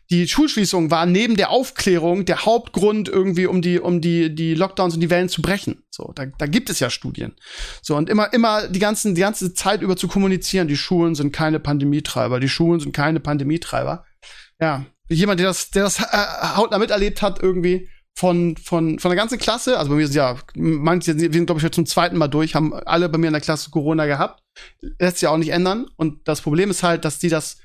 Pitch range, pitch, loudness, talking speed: 160-190 Hz, 175 Hz, -19 LUFS, 220 wpm